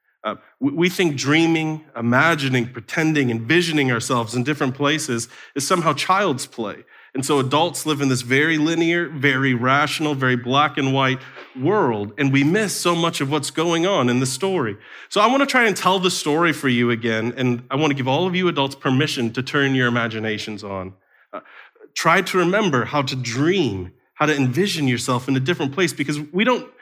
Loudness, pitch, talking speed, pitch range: -19 LUFS, 145 Hz, 195 wpm, 125-165 Hz